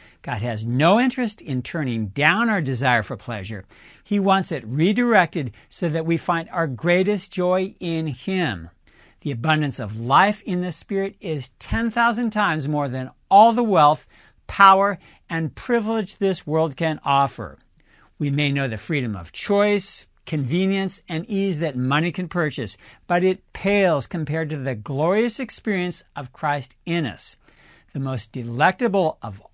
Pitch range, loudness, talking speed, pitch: 130-195 Hz, -21 LUFS, 155 wpm, 160 Hz